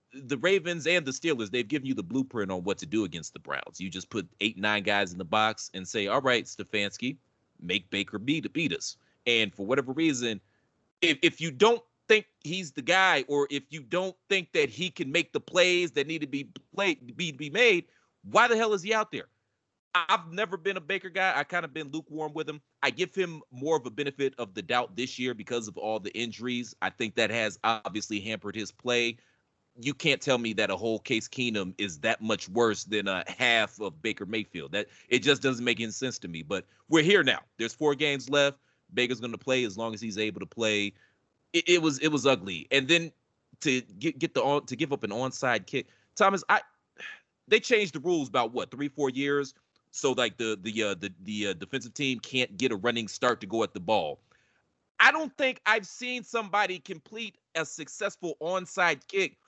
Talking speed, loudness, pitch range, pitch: 220 wpm, -28 LUFS, 110-175 Hz, 135 Hz